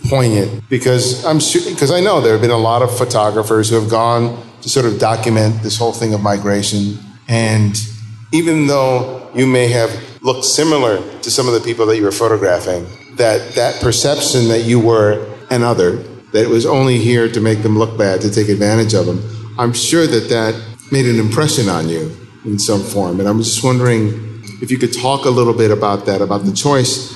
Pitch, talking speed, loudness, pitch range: 115 Hz, 205 wpm, -14 LUFS, 105-125 Hz